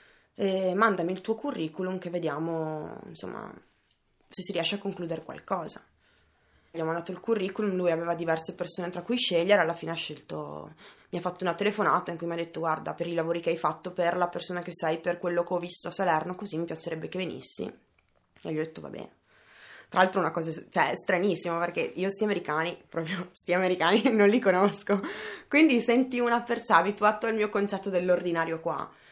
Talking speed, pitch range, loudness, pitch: 200 wpm, 165-195 Hz, -28 LUFS, 175 Hz